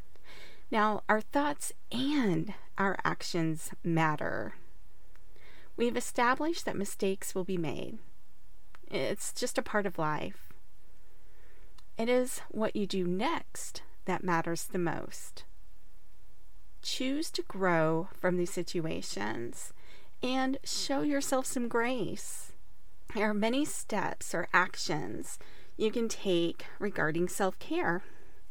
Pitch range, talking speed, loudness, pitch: 180-250 Hz, 110 wpm, -33 LUFS, 210 Hz